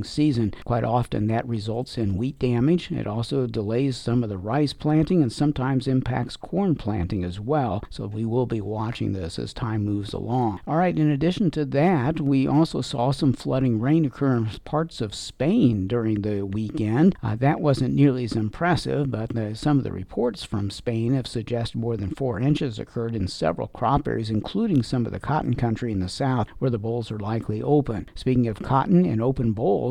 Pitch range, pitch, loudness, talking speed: 110-140 Hz, 120 Hz, -24 LUFS, 200 wpm